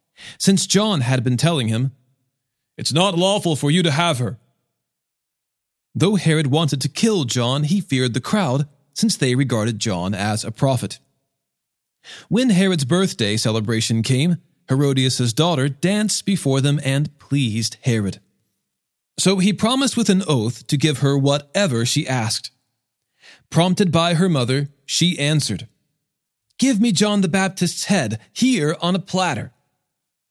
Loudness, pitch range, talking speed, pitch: -19 LUFS, 125-180 Hz, 145 wpm, 145 Hz